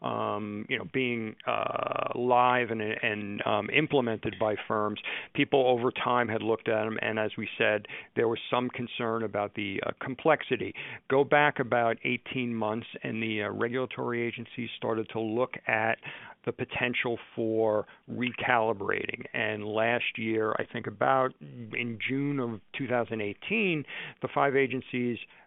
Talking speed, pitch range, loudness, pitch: 145 wpm, 110-125 Hz, -29 LUFS, 120 Hz